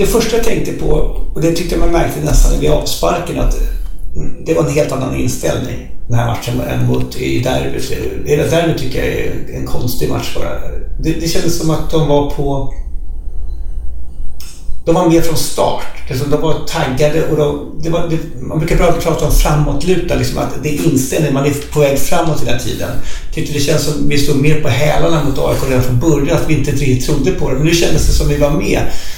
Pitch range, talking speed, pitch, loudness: 125-160 Hz, 210 wpm, 145 Hz, -15 LUFS